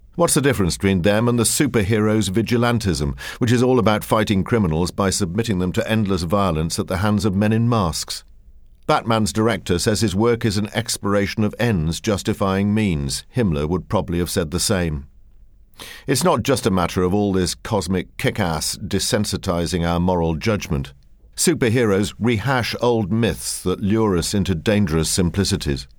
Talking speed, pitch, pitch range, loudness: 165 wpm, 100 Hz, 90-110 Hz, -20 LUFS